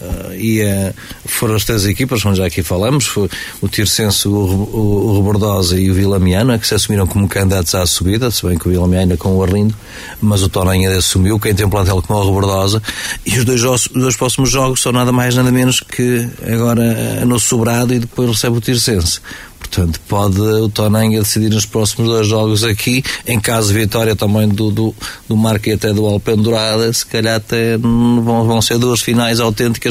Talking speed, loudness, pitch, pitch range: 200 wpm, -14 LUFS, 110 Hz, 100-120 Hz